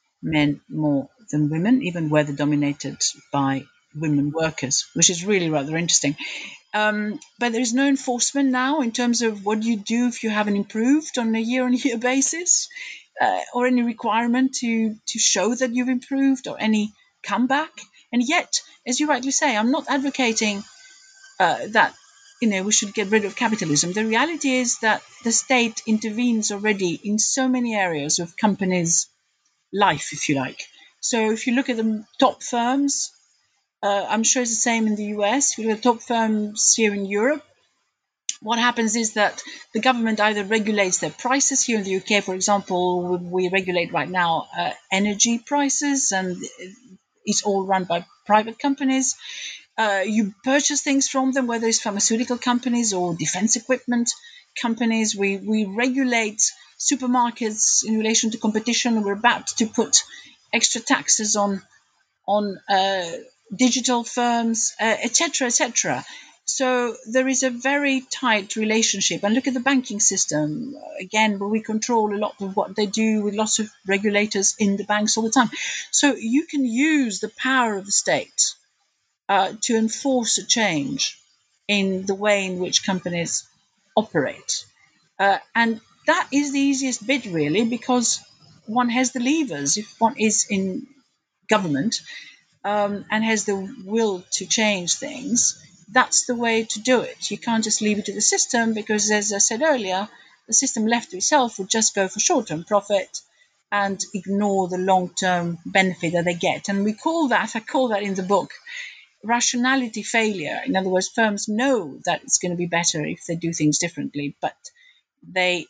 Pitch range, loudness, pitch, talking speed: 200-250 Hz, -21 LUFS, 220 Hz, 170 wpm